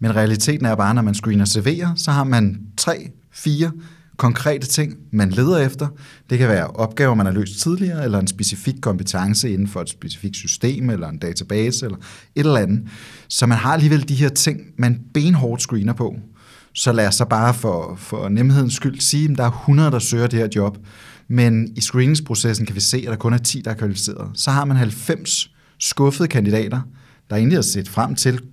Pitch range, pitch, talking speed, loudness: 105-140 Hz, 120 Hz, 210 wpm, -18 LUFS